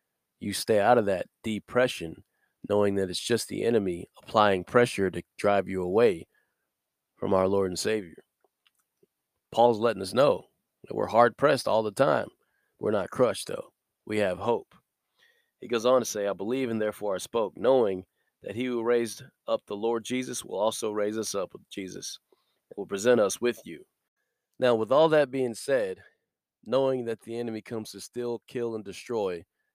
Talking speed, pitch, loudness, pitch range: 180 wpm, 115 Hz, -27 LUFS, 100-125 Hz